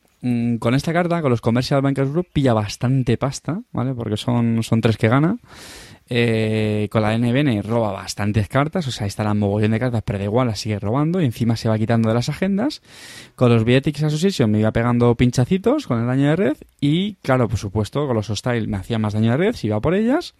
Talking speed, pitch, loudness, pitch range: 225 wpm, 120 Hz, -20 LUFS, 110-140 Hz